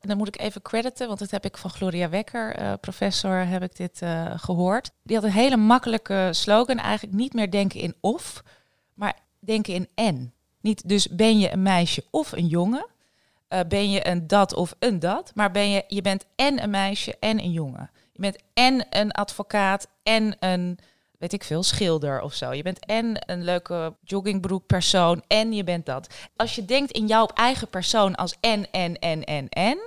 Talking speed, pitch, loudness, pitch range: 200 wpm, 195 Hz, -24 LUFS, 175-215 Hz